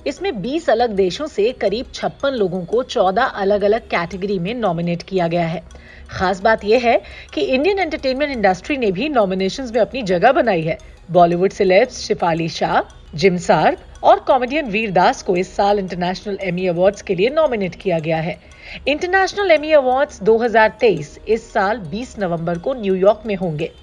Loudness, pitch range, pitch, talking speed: -18 LUFS, 185-265 Hz, 205 Hz, 170 wpm